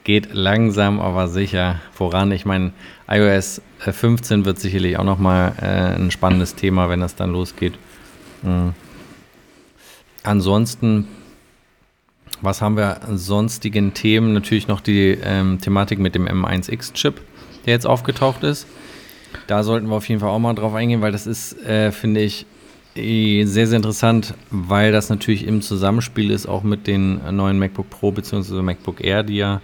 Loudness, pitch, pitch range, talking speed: -19 LUFS, 100 Hz, 95-110 Hz, 155 wpm